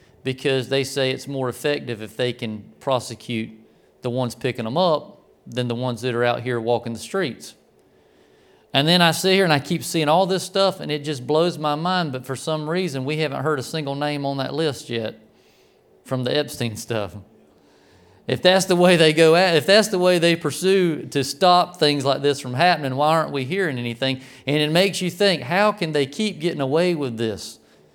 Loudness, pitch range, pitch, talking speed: -21 LUFS, 125-170 Hz, 145 Hz, 215 wpm